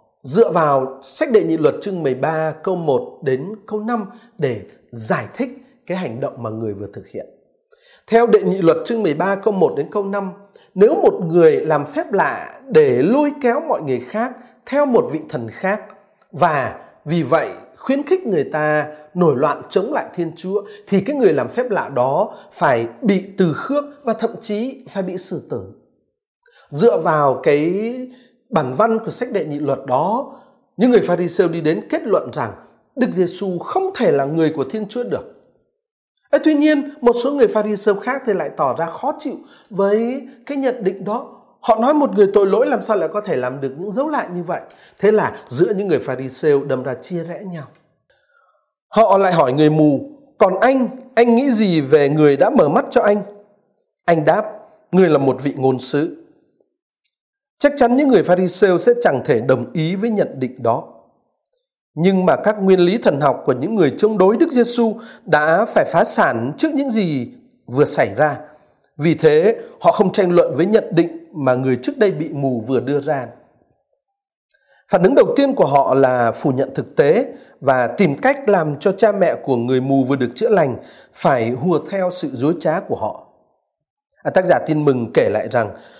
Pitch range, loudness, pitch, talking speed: 155-255 Hz, -17 LUFS, 200 Hz, 200 wpm